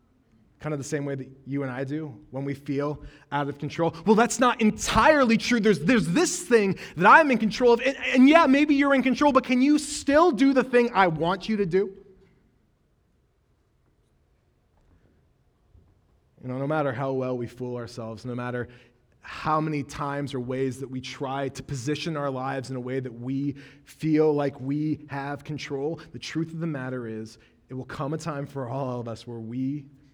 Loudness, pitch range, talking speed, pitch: -24 LUFS, 130-200 Hz, 195 wpm, 145 Hz